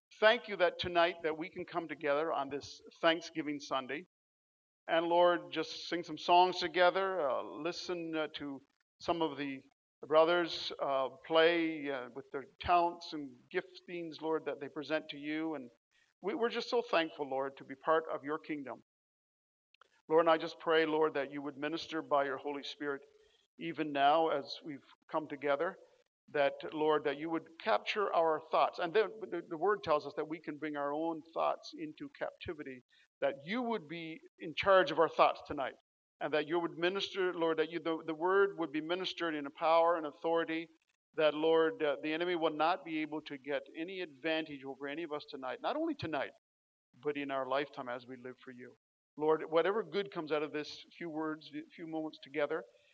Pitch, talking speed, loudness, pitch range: 160 Hz, 195 wpm, -35 LUFS, 150-175 Hz